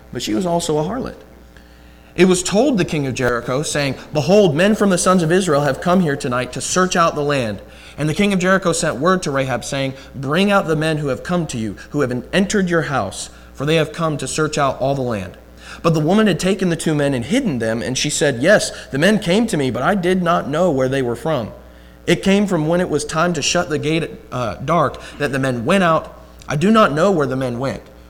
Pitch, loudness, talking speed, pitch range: 150 Hz, -17 LUFS, 255 wpm, 130-180 Hz